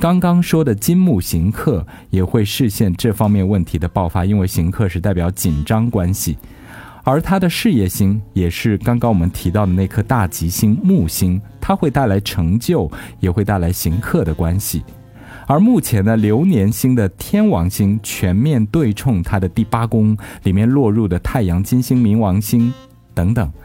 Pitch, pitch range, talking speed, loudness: 105 Hz, 95-120 Hz, 260 characters per minute, -16 LUFS